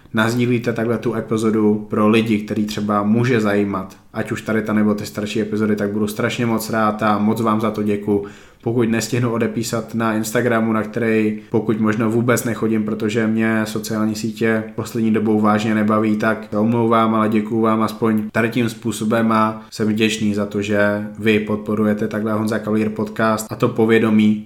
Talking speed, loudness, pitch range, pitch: 180 wpm, -18 LUFS, 105-115 Hz, 110 Hz